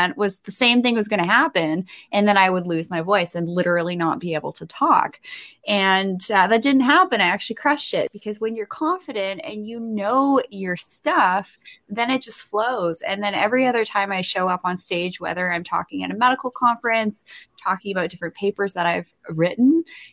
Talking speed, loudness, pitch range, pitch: 205 wpm, -21 LUFS, 180-240 Hz, 205 Hz